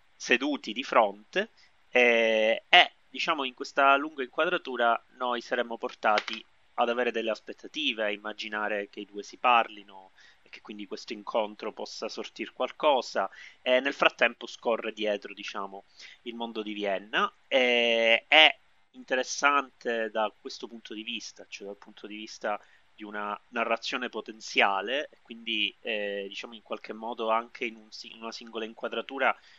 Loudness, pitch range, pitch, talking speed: -27 LUFS, 105-125 Hz, 115 Hz, 150 wpm